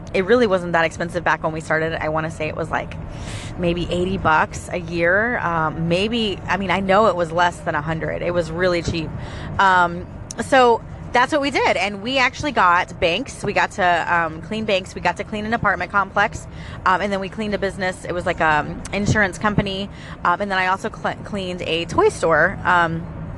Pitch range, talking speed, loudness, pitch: 170-205 Hz, 220 wpm, -20 LUFS, 180 Hz